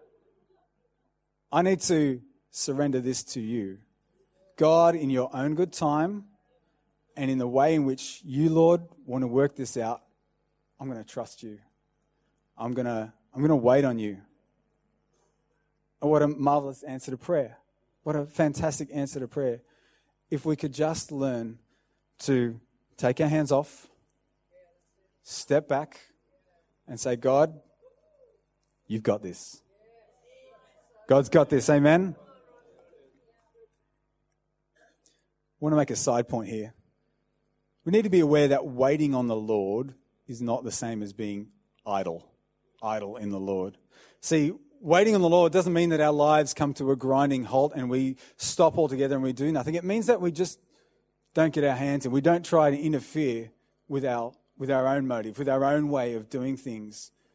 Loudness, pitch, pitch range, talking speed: -26 LUFS, 140 Hz, 125-160 Hz, 160 wpm